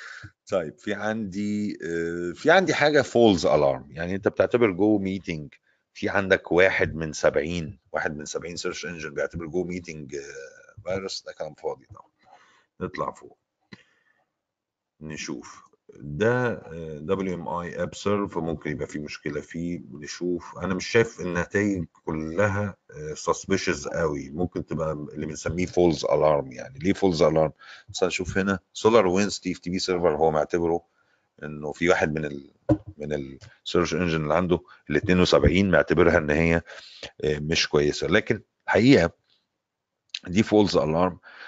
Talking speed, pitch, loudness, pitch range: 140 wpm, 90 Hz, -25 LUFS, 80-100 Hz